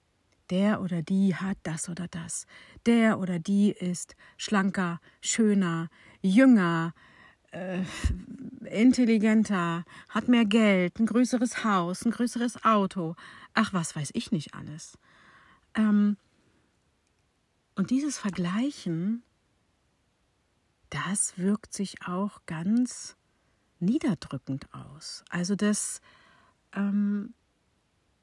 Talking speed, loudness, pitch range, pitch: 95 wpm, -27 LUFS, 170-220 Hz, 195 Hz